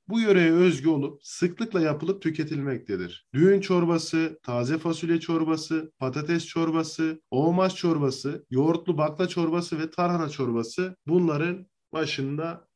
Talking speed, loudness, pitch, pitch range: 115 wpm, -26 LUFS, 160 Hz, 150-175 Hz